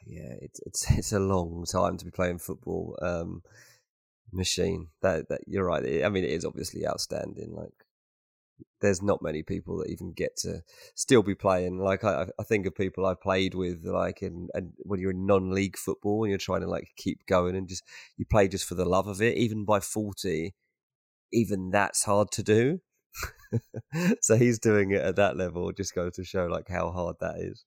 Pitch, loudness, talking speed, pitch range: 95 Hz, -28 LUFS, 205 wpm, 90-110 Hz